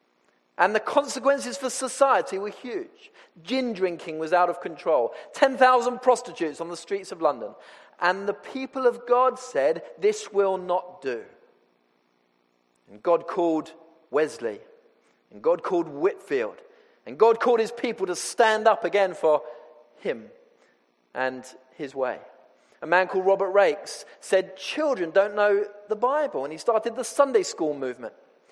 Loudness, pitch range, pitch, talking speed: -25 LUFS, 160-265 Hz, 200 Hz, 145 wpm